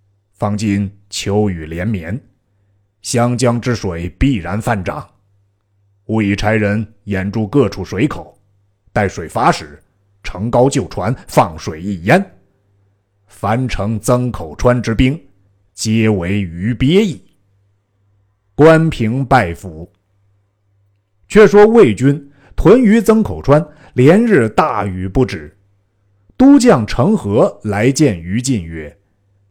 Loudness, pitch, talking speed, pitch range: -14 LUFS, 100 Hz, 155 characters per minute, 100-125 Hz